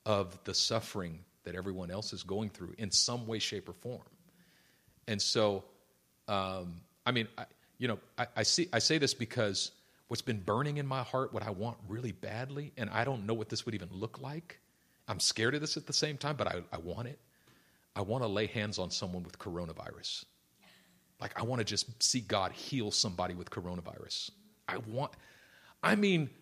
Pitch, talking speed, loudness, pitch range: 110 Hz, 200 wpm, -35 LUFS, 95-130 Hz